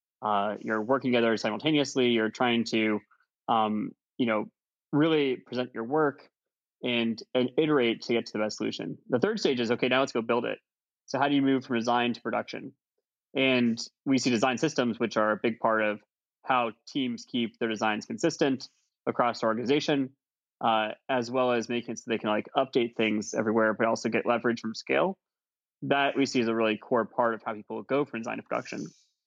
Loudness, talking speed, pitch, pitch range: -28 LUFS, 200 wpm, 120 Hz, 110-135 Hz